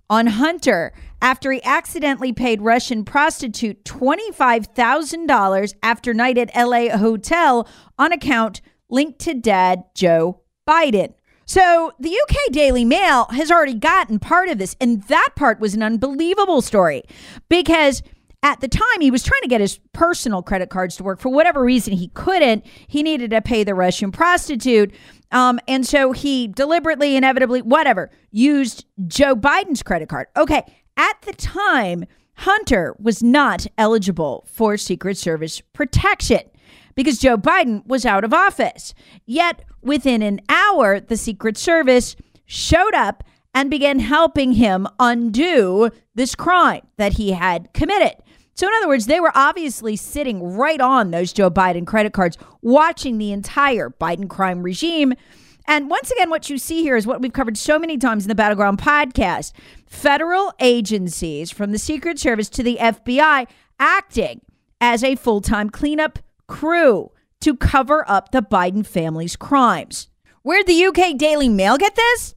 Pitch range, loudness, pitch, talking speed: 215-300 Hz, -17 LUFS, 255 Hz, 155 wpm